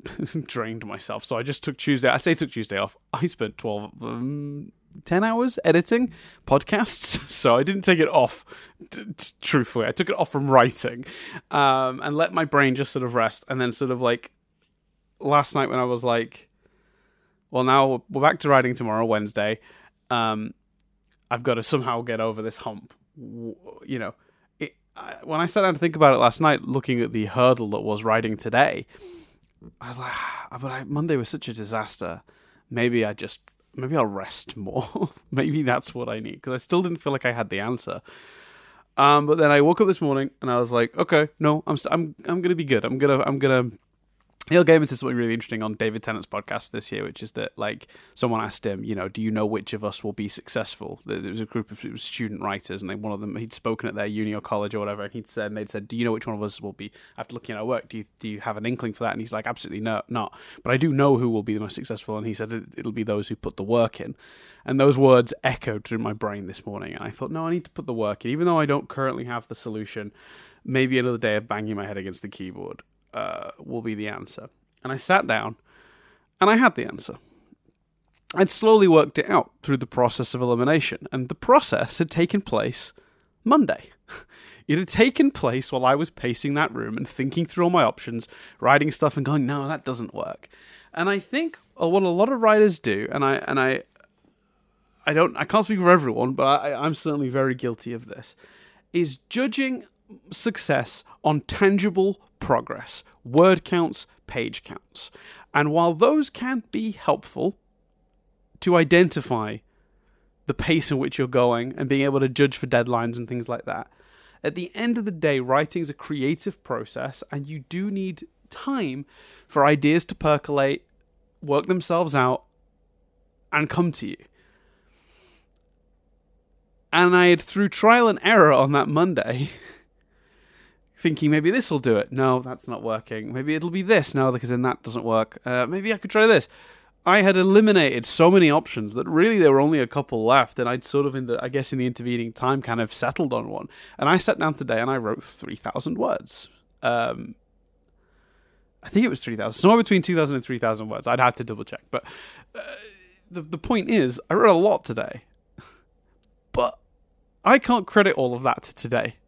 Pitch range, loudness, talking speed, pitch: 115-165 Hz, -23 LUFS, 210 wpm, 130 Hz